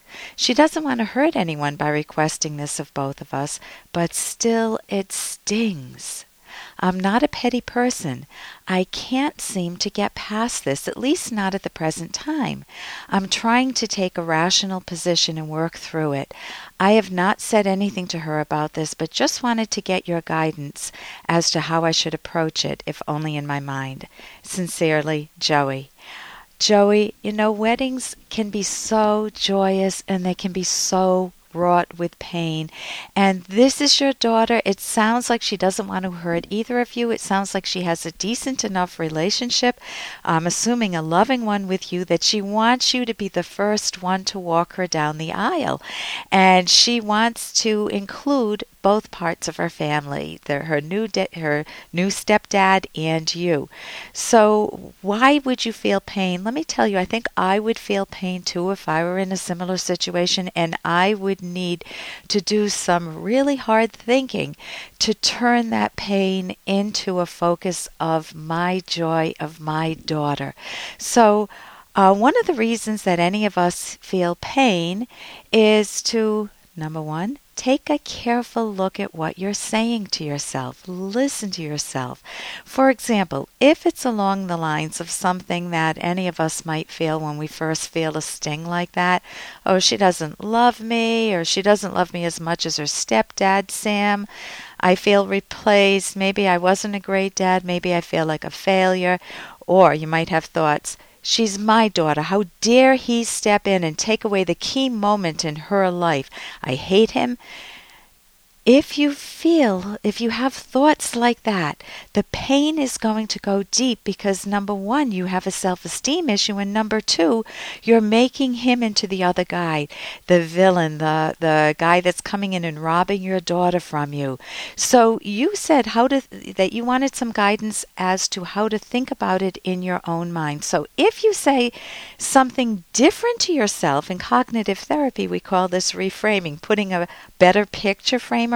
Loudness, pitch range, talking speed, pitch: -20 LUFS, 170-225 Hz, 175 wpm, 195 Hz